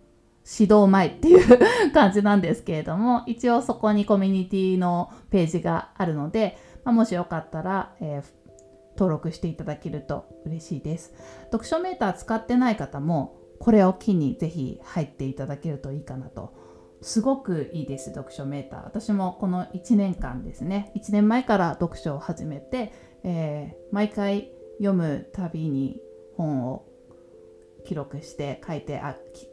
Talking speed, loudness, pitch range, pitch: 300 characters per minute, -24 LUFS, 140-205 Hz, 175 Hz